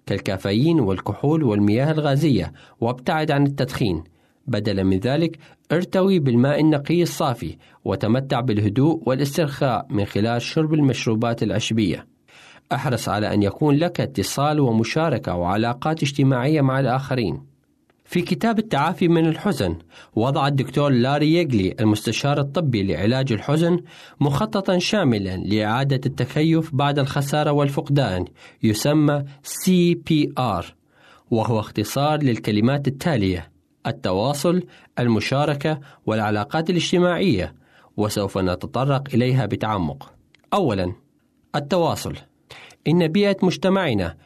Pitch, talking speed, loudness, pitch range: 135 Hz, 100 wpm, -21 LUFS, 110-155 Hz